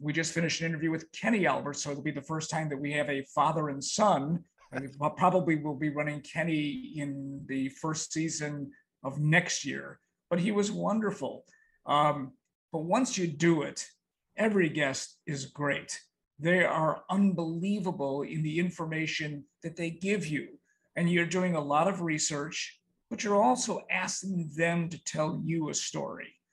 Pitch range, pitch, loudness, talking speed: 150-180 Hz, 160 Hz, -30 LUFS, 170 wpm